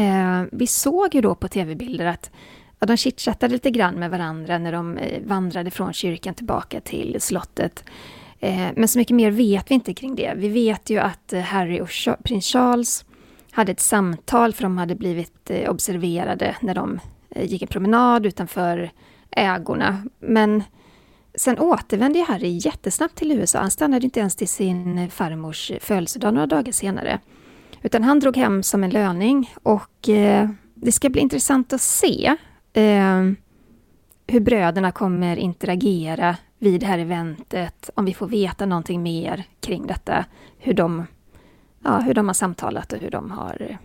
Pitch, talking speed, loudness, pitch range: 200 Hz, 155 wpm, -21 LUFS, 180-235 Hz